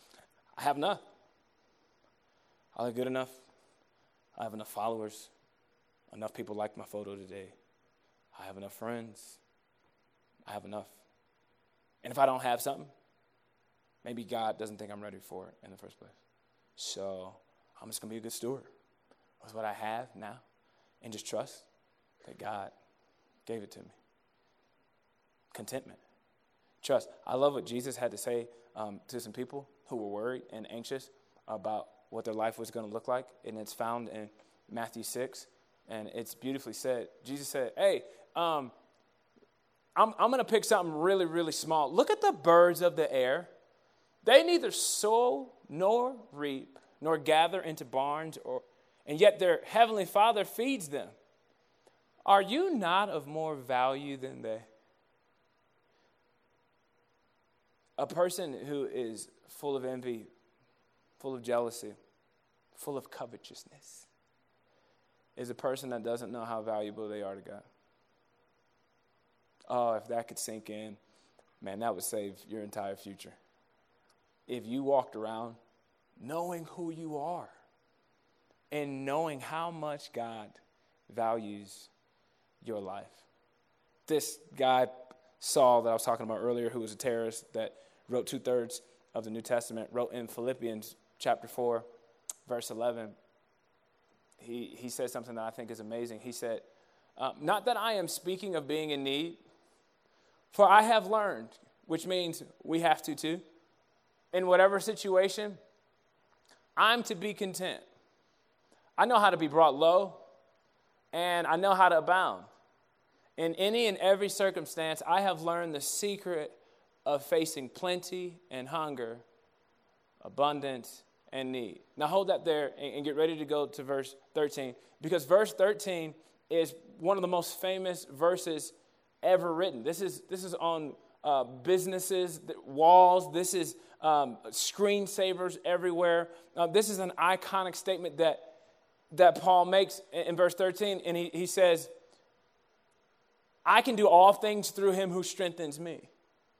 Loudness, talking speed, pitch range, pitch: -31 LUFS, 150 wpm, 120-180 Hz, 150 Hz